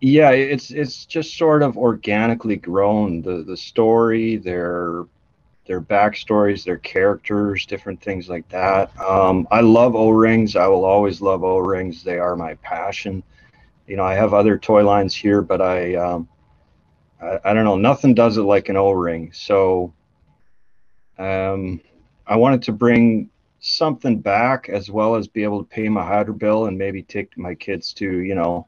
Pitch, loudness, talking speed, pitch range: 100 Hz, -18 LUFS, 175 wpm, 90-110 Hz